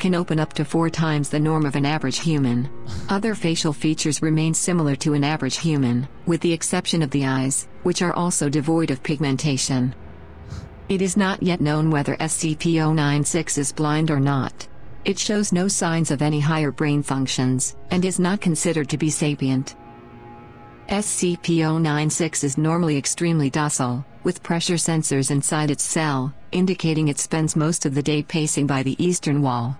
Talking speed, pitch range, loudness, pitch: 170 wpm, 140-165 Hz, -21 LUFS, 155 Hz